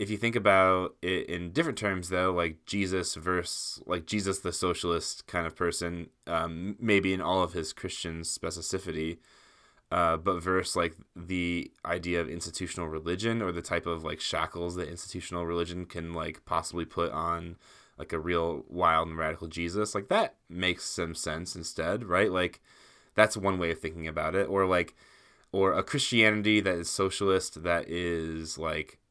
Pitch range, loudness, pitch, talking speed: 85-95 Hz, -30 LUFS, 85 Hz, 170 wpm